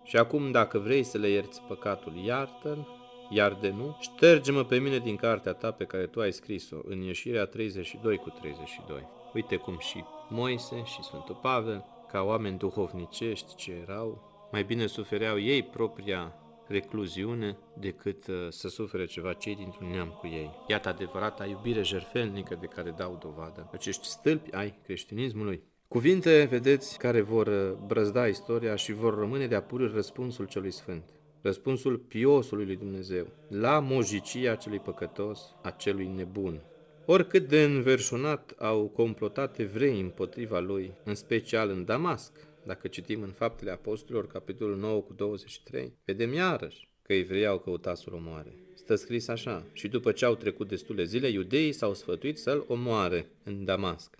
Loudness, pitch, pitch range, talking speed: -30 LUFS, 105 Hz, 95-125 Hz, 150 wpm